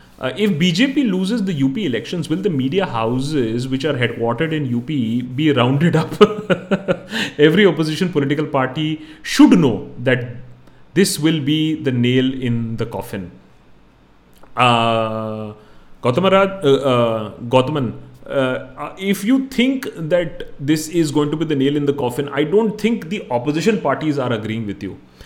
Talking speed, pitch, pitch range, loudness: 155 wpm, 145 Hz, 120-180 Hz, -18 LUFS